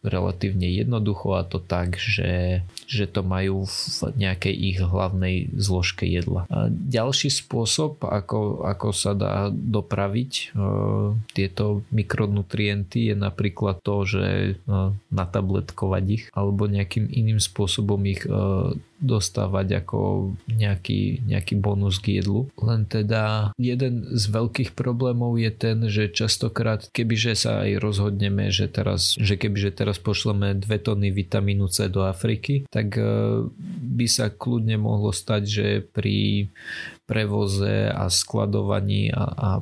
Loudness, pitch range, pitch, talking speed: -24 LUFS, 100-115 Hz, 105 Hz, 130 wpm